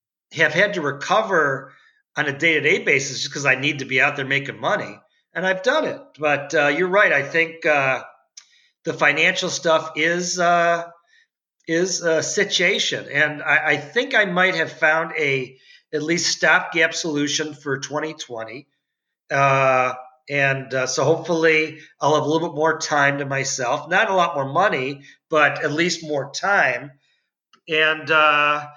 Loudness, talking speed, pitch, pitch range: -19 LUFS, 165 wpm, 155 Hz, 140-170 Hz